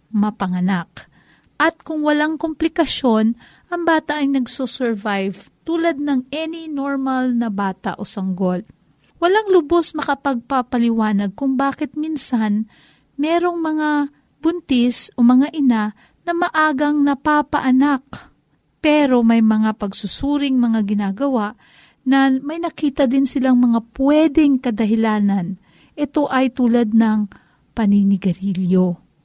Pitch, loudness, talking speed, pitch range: 260 Hz, -18 LUFS, 105 wpm, 215-295 Hz